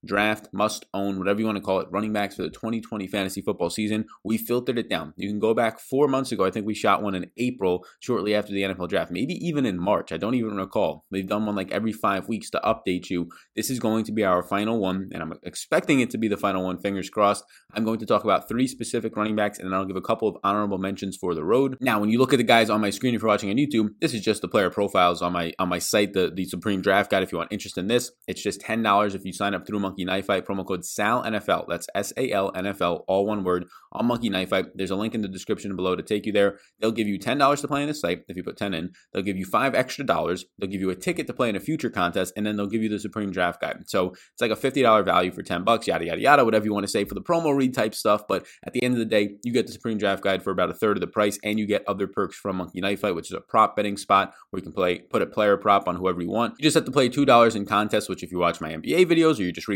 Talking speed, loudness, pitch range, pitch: 300 wpm, -24 LUFS, 95-110 Hz, 100 Hz